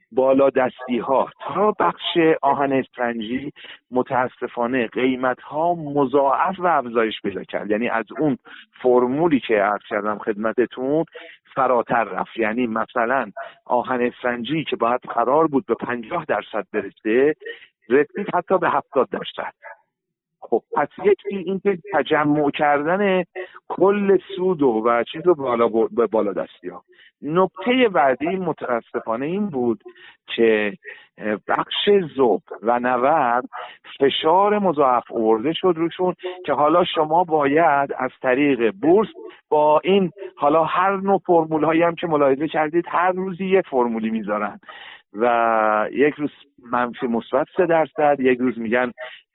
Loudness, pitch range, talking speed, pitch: -20 LUFS, 120-180 Hz, 130 wpm, 145 Hz